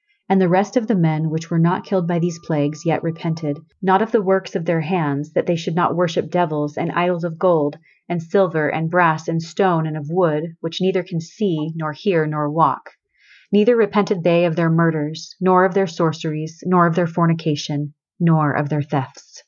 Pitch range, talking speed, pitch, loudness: 155-185 Hz, 205 wpm, 170 Hz, -19 LUFS